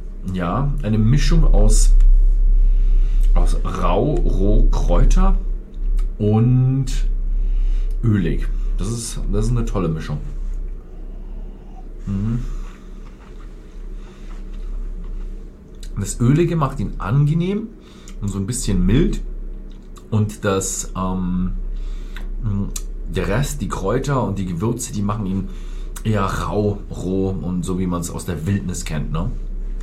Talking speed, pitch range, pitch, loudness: 100 wpm, 85-115 Hz, 95 Hz, -21 LUFS